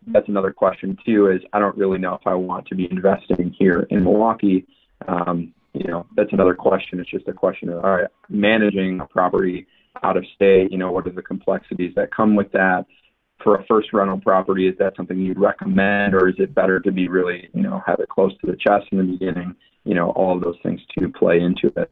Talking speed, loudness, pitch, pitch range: 235 wpm, -19 LUFS, 95 Hz, 90-100 Hz